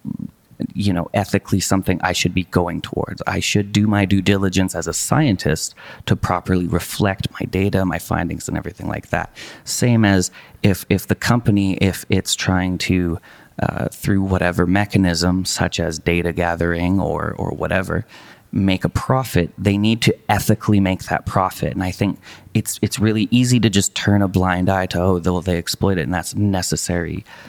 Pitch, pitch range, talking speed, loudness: 95 Hz, 90-105 Hz, 180 wpm, -19 LUFS